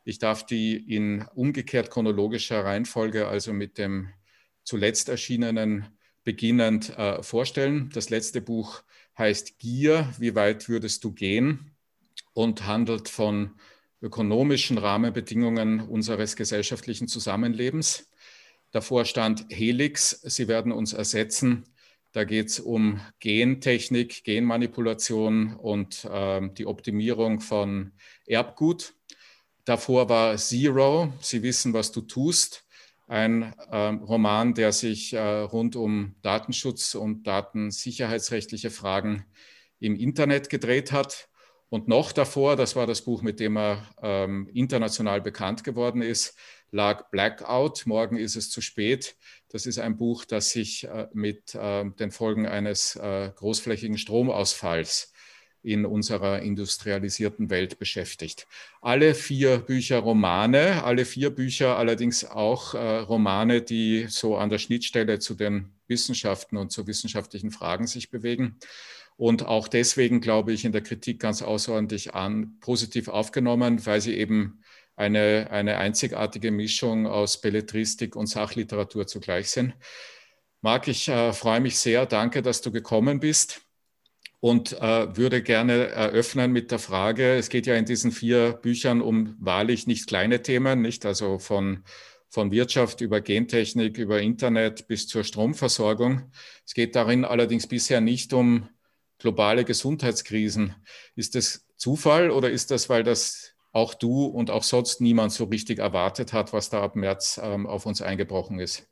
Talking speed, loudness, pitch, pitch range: 135 wpm, -25 LUFS, 115 Hz, 105-120 Hz